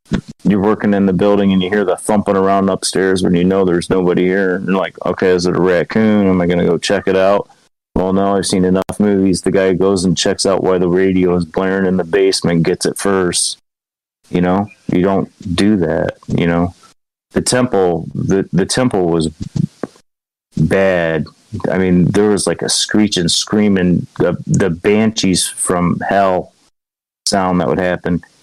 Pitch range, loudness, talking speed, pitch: 90-100 Hz, -14 LUFS, 190 wpm, 95 Hz